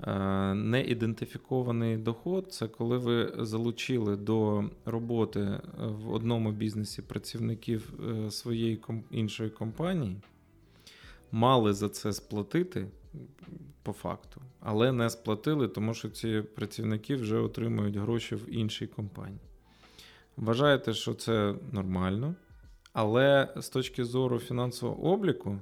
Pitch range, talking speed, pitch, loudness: 105-125 Hz, 105 wpm, 115 Hz, -31 LUFS